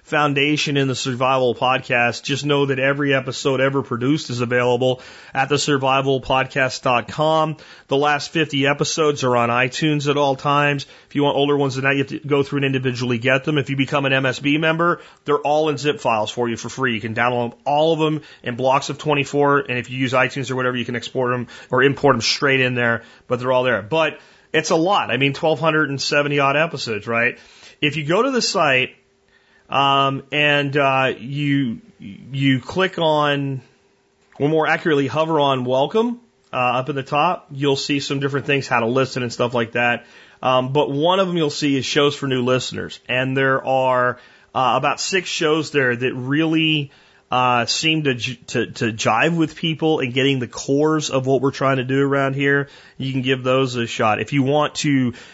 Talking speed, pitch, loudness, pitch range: 205 wpm, 140 Hz, -19 LUFS, 130-150 Hz